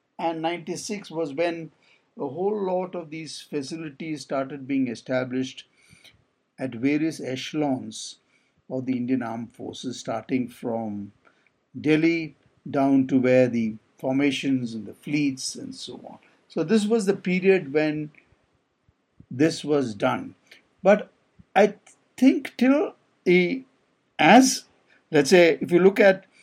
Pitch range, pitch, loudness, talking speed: 130-185 Hz, 155 Hz, -24 LUFS, 125 wpm